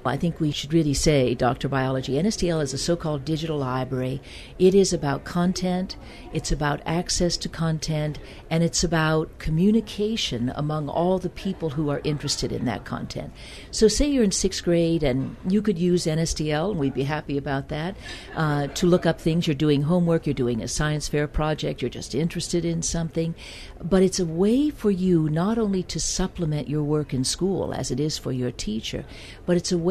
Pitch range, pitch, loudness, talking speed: 145-180 Hz, 160 Hz, -24 LUFS, 195 wpm